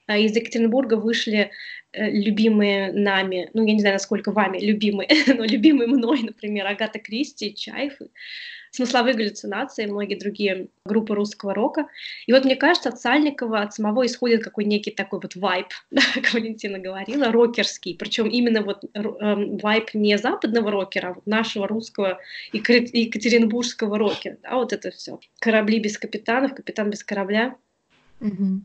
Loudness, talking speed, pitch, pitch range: -22 LUFS, 140 wpm, 220 Hz, 205-240 Hz